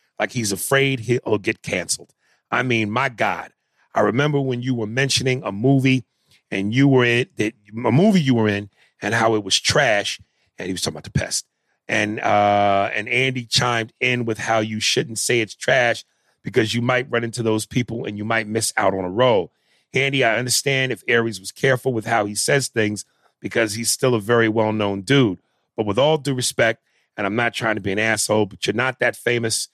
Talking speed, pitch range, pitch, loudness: 210 wpm, 105-130 Hz, 115 Hz, -20 LUFS